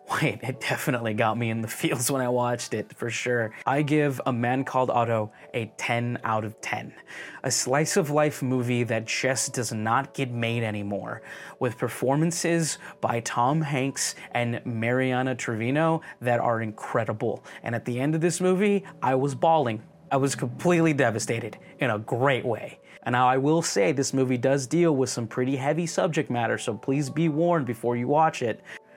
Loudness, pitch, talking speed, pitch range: -26 LUFS, 130 Hz, 180 wpm, 120-150 Hz